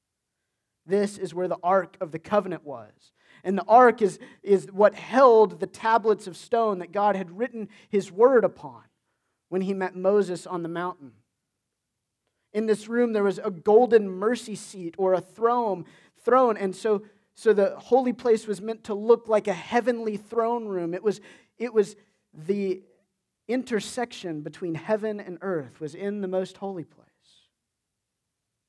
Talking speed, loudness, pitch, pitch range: 165 wpm, -25 LUFS, 200 Hz, 180-220 Hz